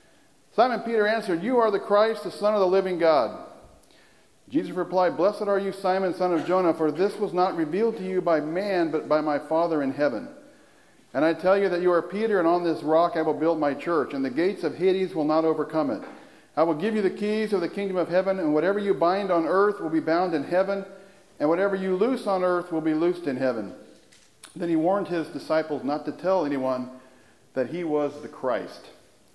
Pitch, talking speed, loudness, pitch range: 175 Hz, 225 wpm, -25 LUFS, 155-195 Hz